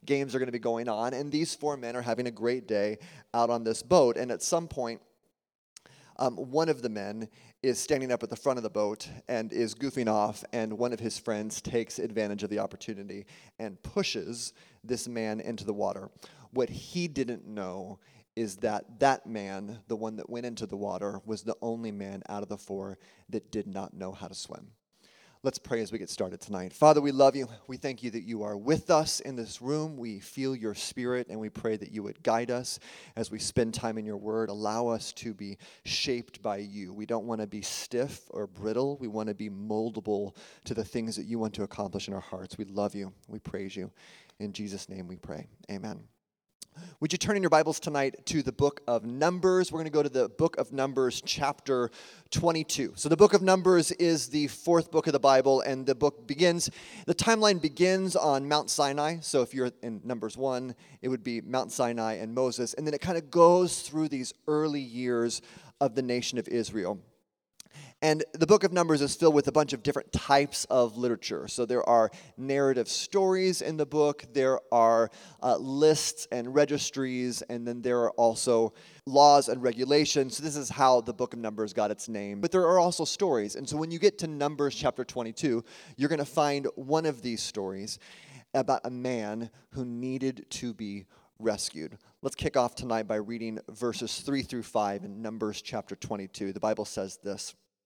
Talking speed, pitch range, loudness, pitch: 210 wpm, 110-145 Hz, -29 LUFS, 120 Hz